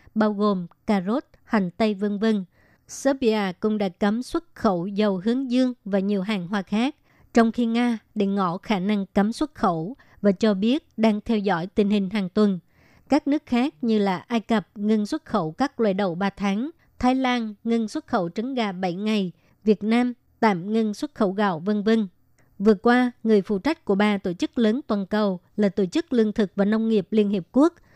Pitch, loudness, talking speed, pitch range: 215 Hz, -24 LUFS, 210 wpm, 200-235 Hz